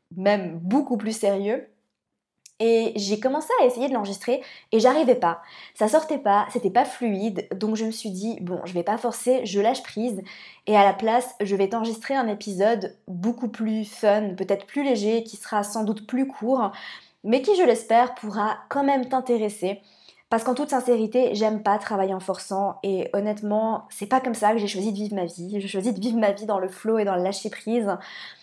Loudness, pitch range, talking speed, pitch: -24 LUFS, 200-240 Hz, 205 wpm, 215 Hz